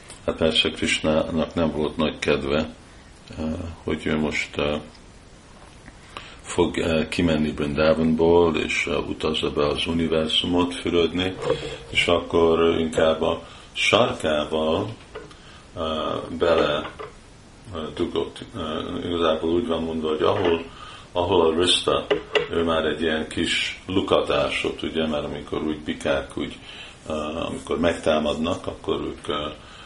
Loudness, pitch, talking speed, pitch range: -23 LUFS, 80 Hz, 100 wpm, 75-85 Hz